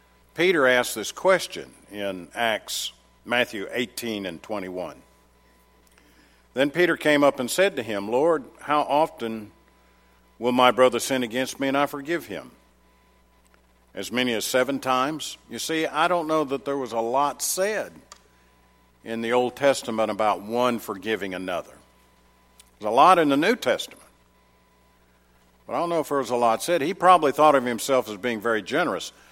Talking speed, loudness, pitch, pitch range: 165 wpm, -23 LUFS, 120 Hz, 90-140 Hz